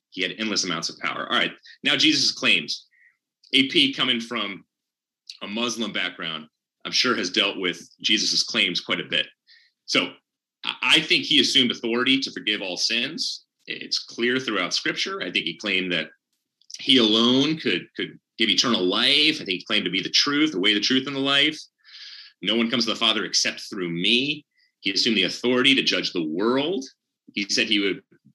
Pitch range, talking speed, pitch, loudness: 105-145 Hz, 190 wpm, 120 Hz, -21 LUFS